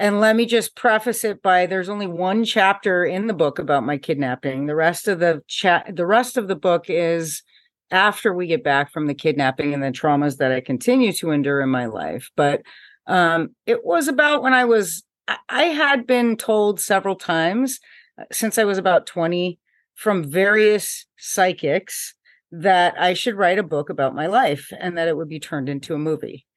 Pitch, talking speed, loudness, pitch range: 180 Hz, 200 wpm, -20 LUFS, 155-215 Hz